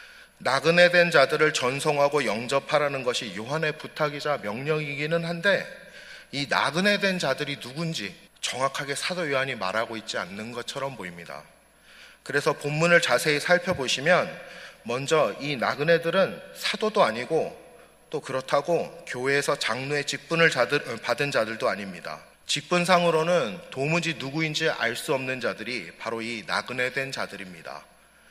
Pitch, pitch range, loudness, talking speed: 145 Hz, 130-170 Hz, -25 LUFS, 320 characters per minute